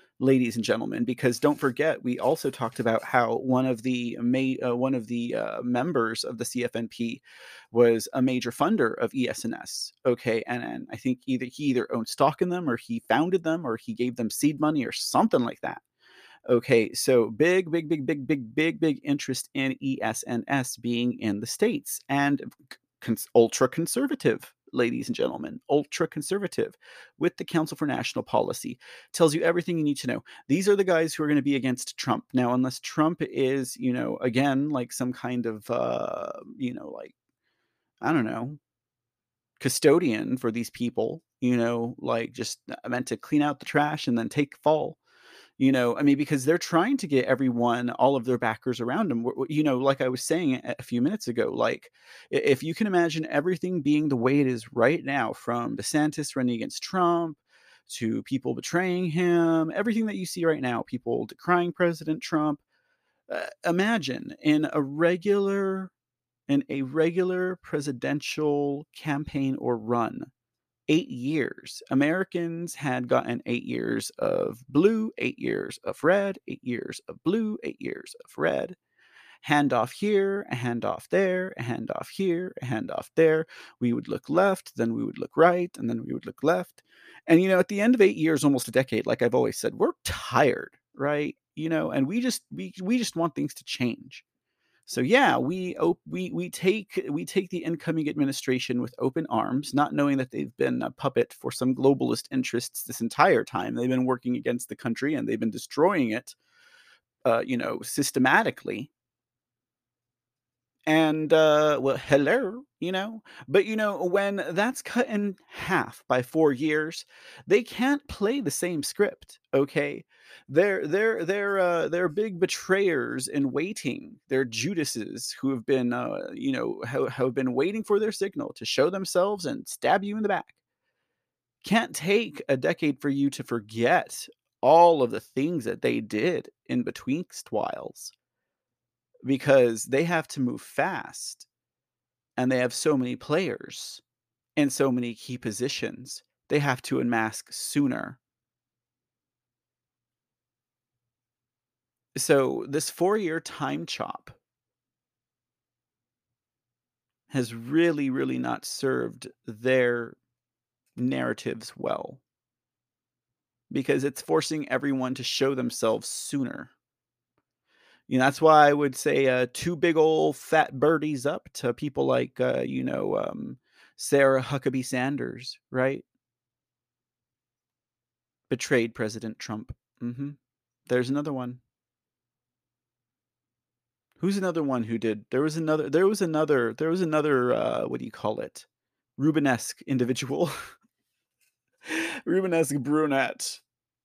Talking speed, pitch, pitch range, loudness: 155 wpm, 140 Hz, 125-170 Hz, -26 LUFS